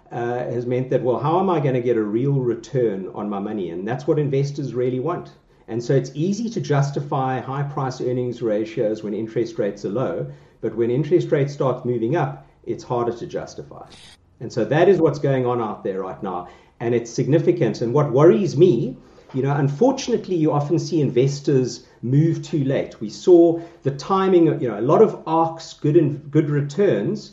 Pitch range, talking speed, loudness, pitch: 120-165 Hz, 200 wpm, -21 LUFS, 140 Hz